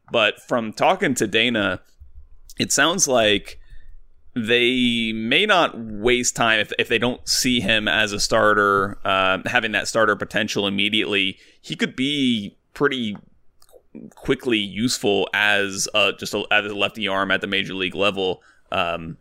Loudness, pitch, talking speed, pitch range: -20 LUFS, 100 Hz, 150 wpm, 95-120 Hz